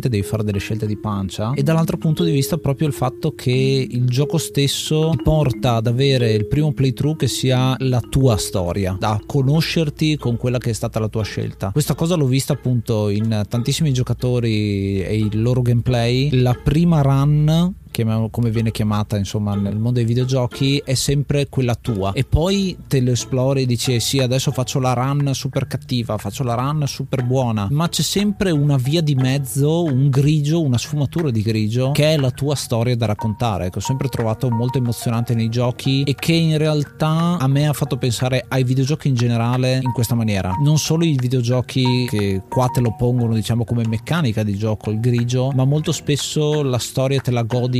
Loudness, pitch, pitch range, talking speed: -19 LUFS, 130 Hz, 115-145 Hz, 195 wpm